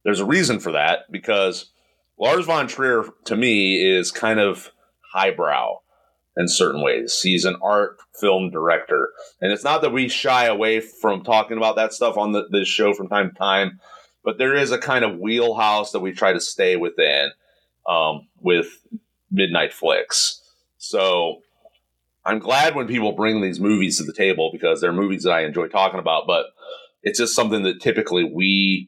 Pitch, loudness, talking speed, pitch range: 105 Hz, -20 LUFS, 180 wpm, 95-120 Hz